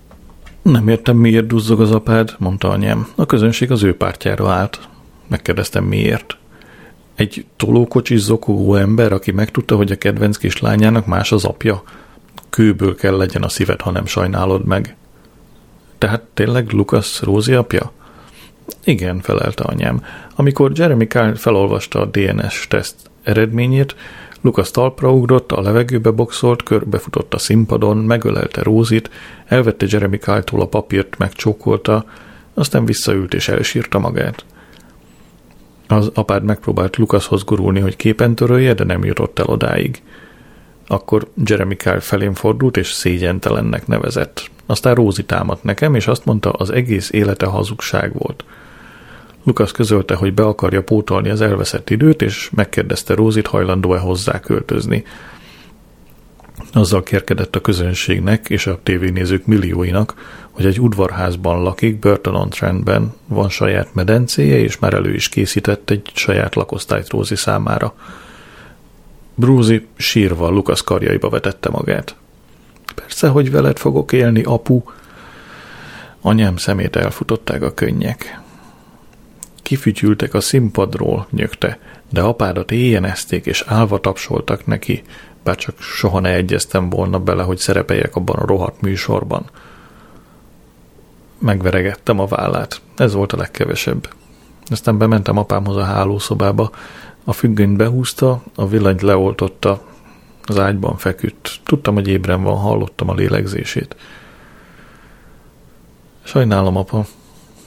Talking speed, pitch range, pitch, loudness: 125 wpm, 95-115 Hz, 105 Hz, -16 LUFS